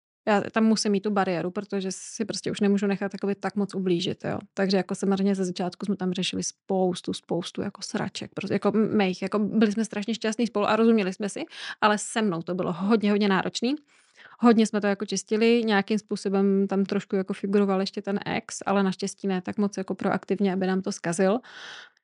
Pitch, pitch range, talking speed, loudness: 200 Hz, 190-215 Hz, 205 wpm, -26 LUFS